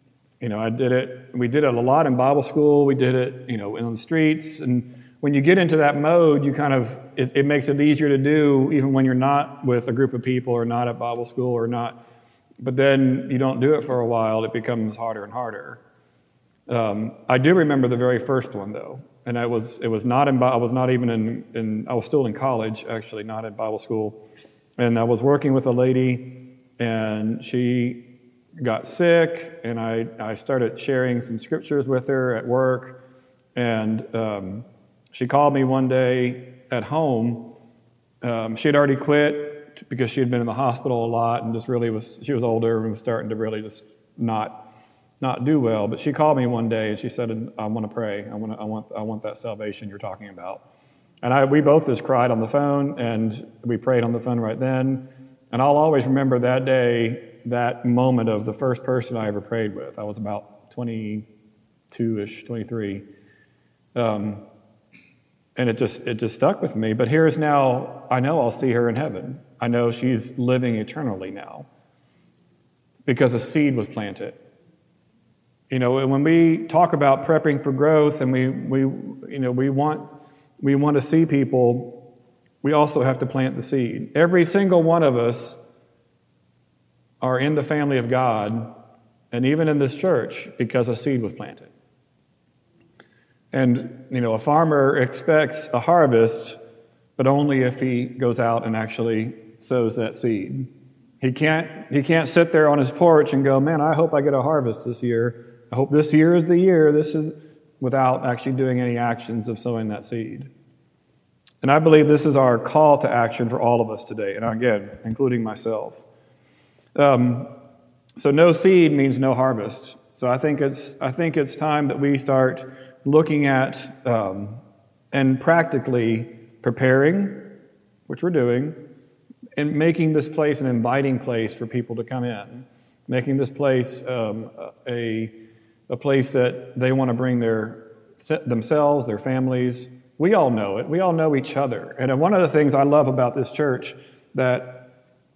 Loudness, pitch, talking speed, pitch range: -21 LUFS, 125 Hz, 190 wpm, 115-140 Hz